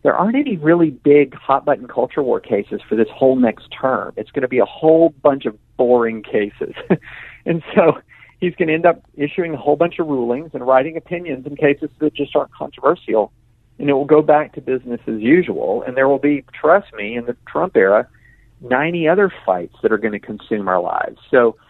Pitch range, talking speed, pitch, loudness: 120-155 Hz, 215 wpm, 145 Hz, -17 LUFS